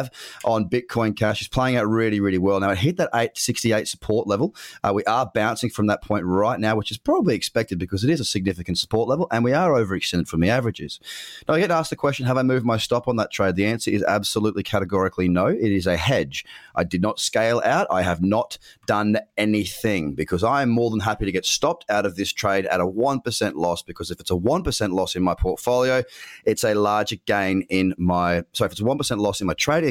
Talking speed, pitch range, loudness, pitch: 235 wpm, 95-120 Hz, -22 LUFS, 105 Hz